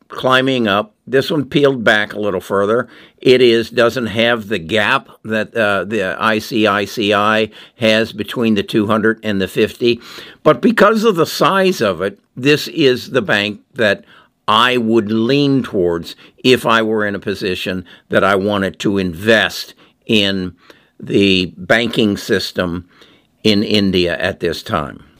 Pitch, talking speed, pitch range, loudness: 110 Hz, 150 wpm, 105-125 Hz, -15 LUFS